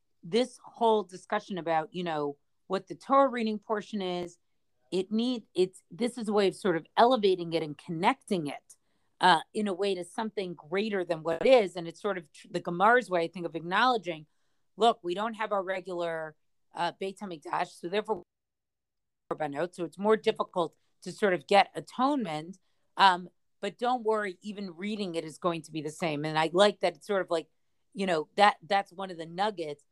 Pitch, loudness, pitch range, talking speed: 185 Hz, -29 LUFS, 170-210 Hz, 200 wpm